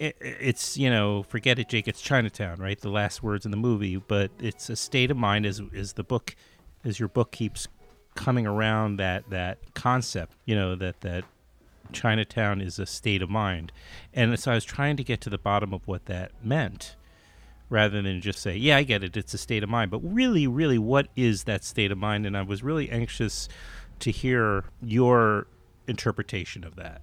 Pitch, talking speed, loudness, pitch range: 105 Hz, 200 wpm, -27 LUFS, 95-120 Hz